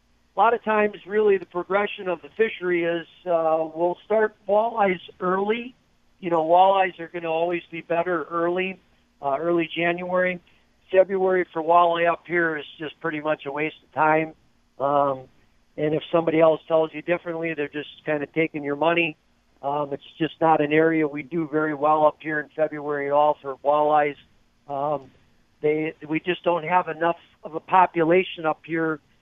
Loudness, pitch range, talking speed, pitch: -23 LUFS, 150-175 Hz, 180 wpm, 160 Hz